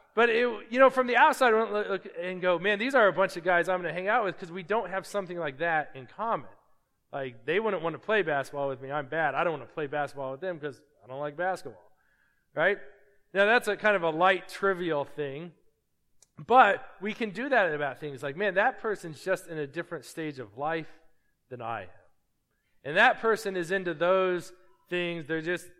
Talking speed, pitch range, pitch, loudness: 230 wpm, 150-205 Hz, 180 Hz, -28 LUFS